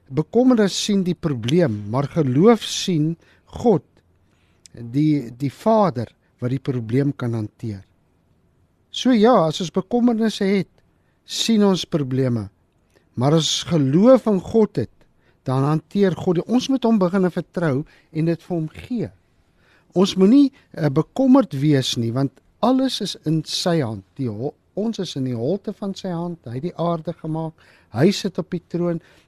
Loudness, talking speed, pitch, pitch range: -20 LUFS, 155 wpm, 160 Hz, 130-195 Hz